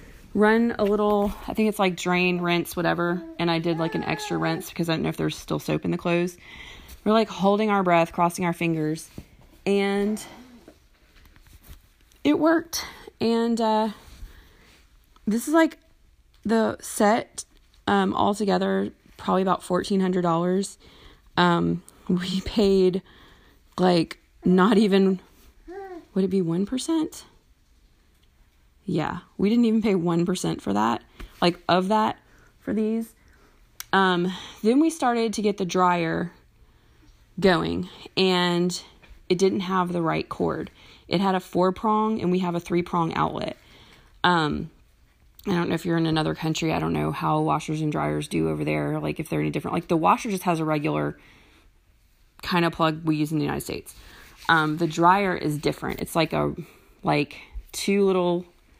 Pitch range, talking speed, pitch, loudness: 155-200 Hz, 155 wpm, 180 Hz, -24 LUFS